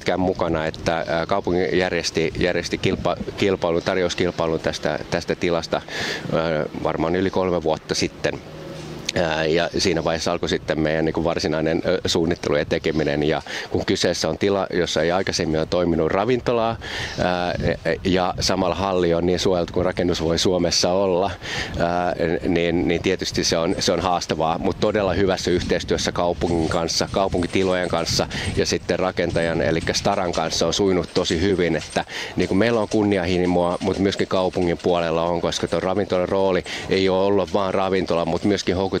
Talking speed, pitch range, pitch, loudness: 155 wpm, 85-95 Hz, 90 Hz, -21 LUFS